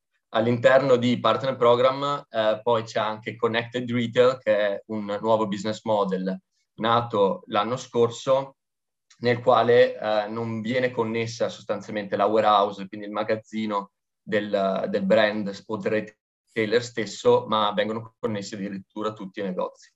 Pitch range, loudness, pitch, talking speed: 105-120 Hz, -24 LUFS, 110 Hz, 130 wpm